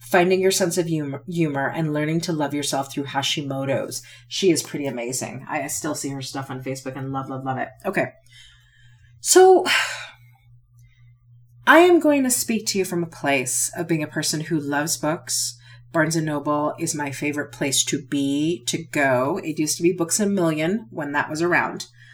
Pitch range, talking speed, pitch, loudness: 130-165 Hz, 190 wpm, 145 Hz, -22 LUFS